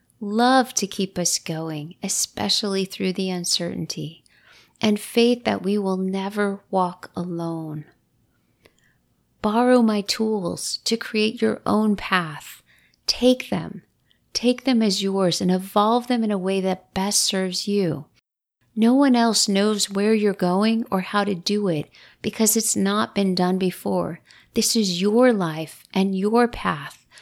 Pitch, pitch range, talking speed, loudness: 200 Hz, 185-220 Hz, 145 wpm, -22 LUFS